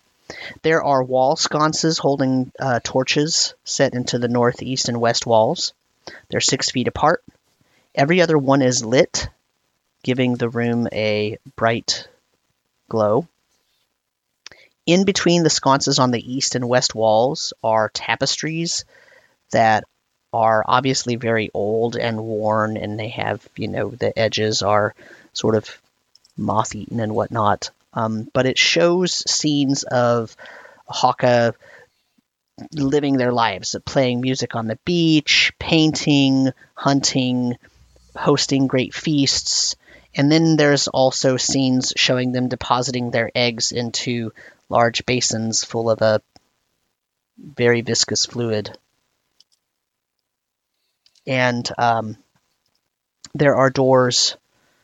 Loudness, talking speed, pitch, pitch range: -19 LUFS, 115 wpm, 125 Hz, 115-135 Hz